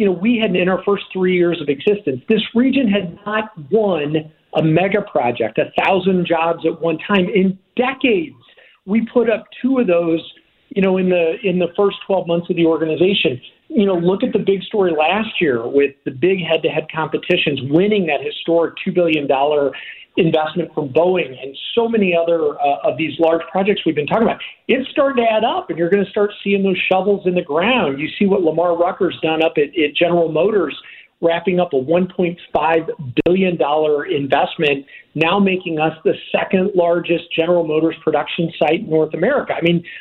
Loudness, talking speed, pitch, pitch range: -17 LUFS, 195 wpm, 175 Hz, 160-200 Hz